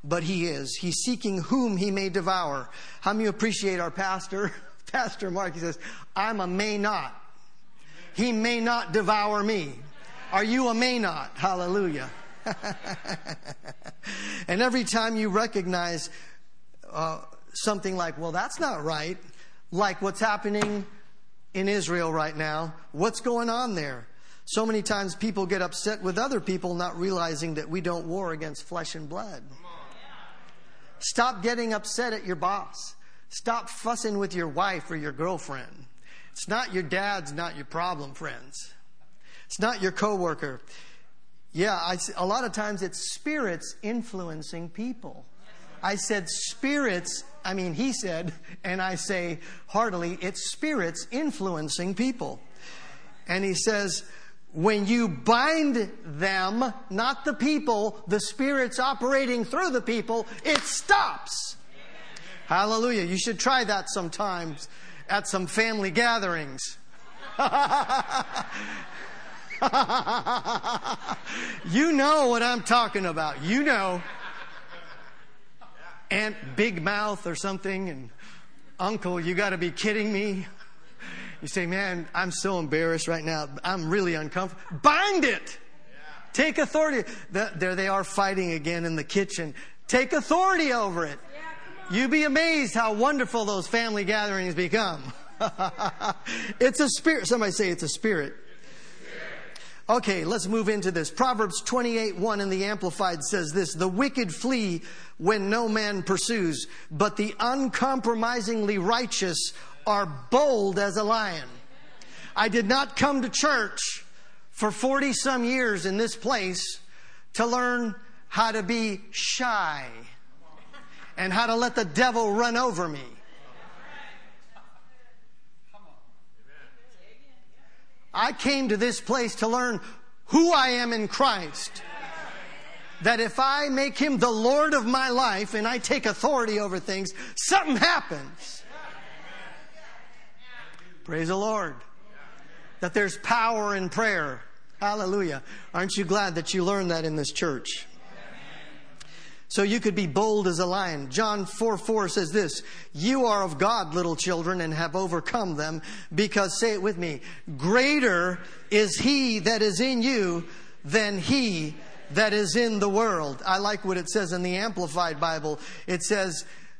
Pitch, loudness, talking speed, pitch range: 205 Hz, -26 LUFS, 135 wpm, 180-230 Hz